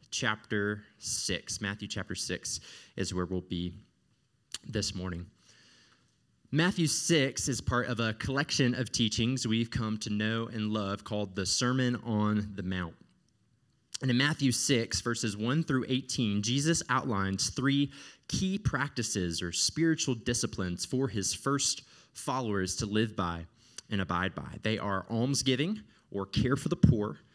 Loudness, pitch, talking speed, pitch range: -31 LUFS, 110 Hz, 145 wpm, 100-130 Hz